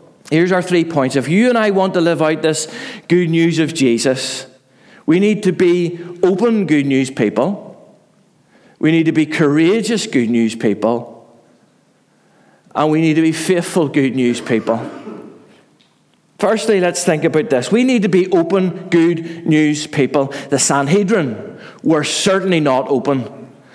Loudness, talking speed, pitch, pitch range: -15 LUFS, 155 wpm, 160 Hz, 135-180 Hz